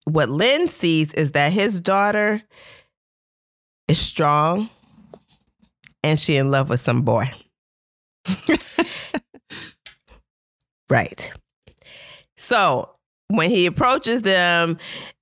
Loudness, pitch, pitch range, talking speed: -19 LUFS, 175 Hz, 150-210 Hz, 85 wpm